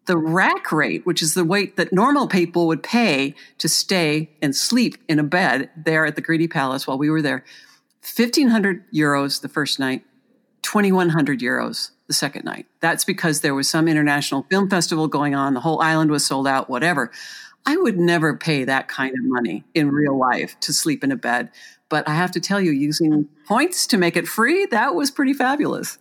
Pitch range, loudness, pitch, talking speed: 145-195 Hz, -19 LUFS, 160 Hz, 210 wpm